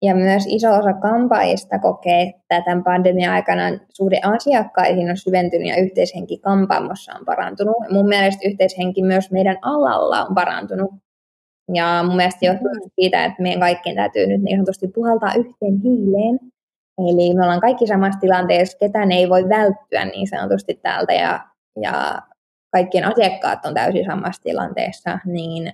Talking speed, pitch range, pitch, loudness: 150 wpm, 180-205 Hz, 195 Hz, -18 LUFS